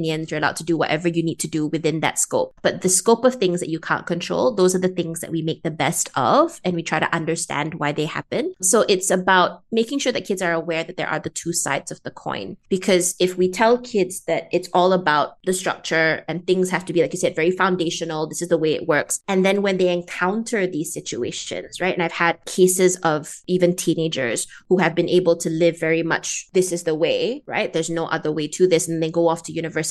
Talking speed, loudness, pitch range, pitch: 250 wpm, -21 LUFS, 160-185 Hz, 170 Hz